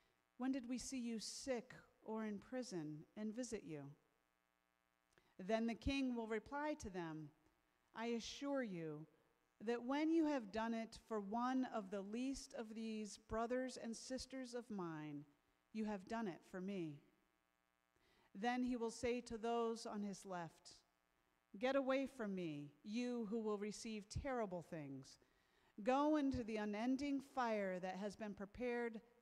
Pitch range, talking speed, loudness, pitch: 170-245 Hz, 150 wpm, -46 LUFS, 220 Hz